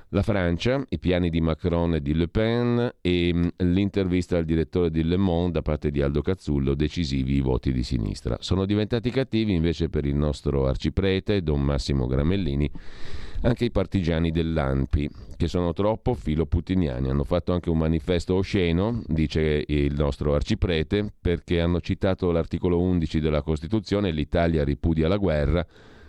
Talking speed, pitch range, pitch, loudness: 155 wpm, 75-95 Hz, 85 Hz, -25 LUFS